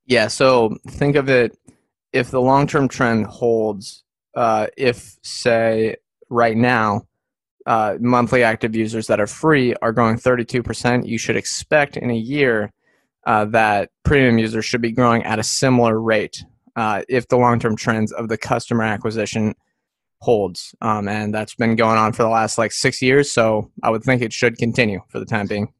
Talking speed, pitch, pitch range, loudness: 175 wpm, 115 Hz, 110-125 Hz, -18 LUFS